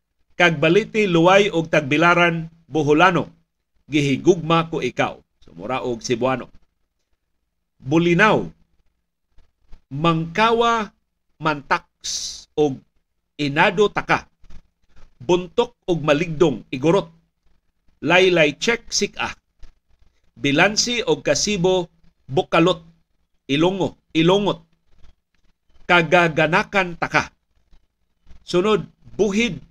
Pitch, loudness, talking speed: 160 Hz, -19 LUFS, 70 wpm